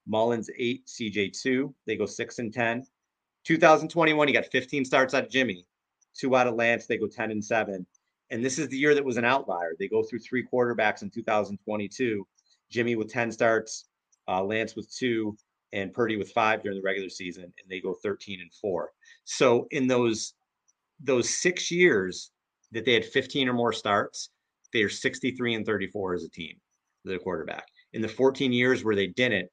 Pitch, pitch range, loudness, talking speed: 115 Hz, 105-130 Hz, -27 LUFS, 185 wpm